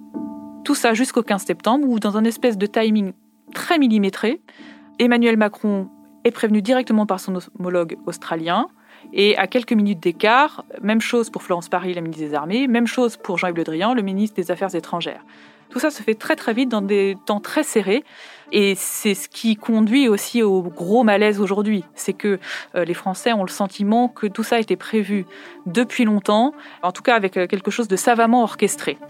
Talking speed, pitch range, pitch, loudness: 190 wpm, 190-235 Hz, 210 Hz, -20 LUFS